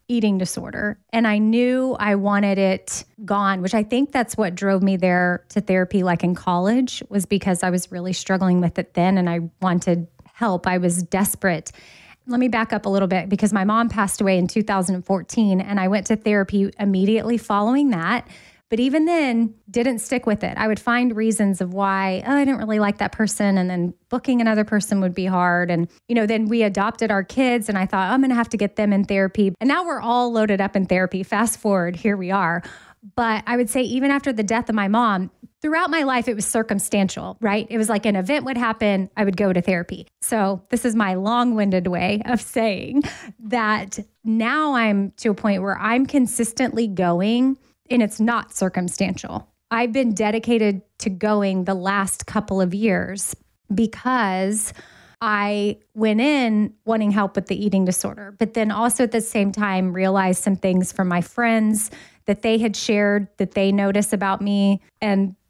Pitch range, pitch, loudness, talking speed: 195-230 Hz, 210 Hz, -21 LUFS, 200 wpm